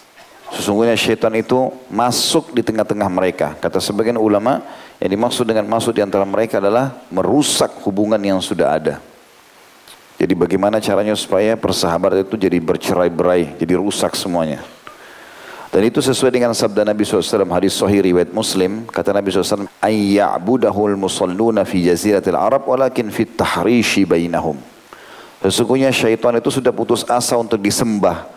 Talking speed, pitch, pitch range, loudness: 135 wpm, 105 Hz, 95-115 Hz, -16 LUFS